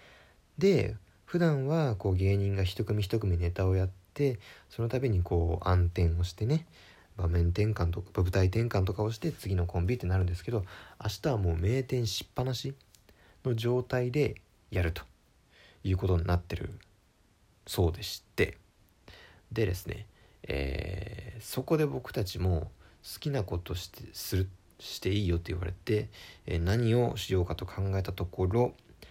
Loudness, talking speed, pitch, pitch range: -31 LUFS, 290 characters per minute, 100 Hz, 90-115 Hz